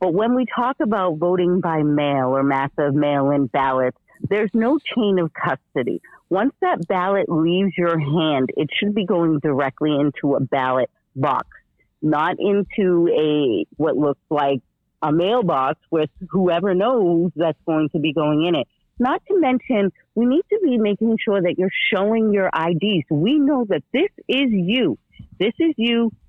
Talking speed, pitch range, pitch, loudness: 165 wpm, 150-225 Hz, 180 Hz, -20 LUFS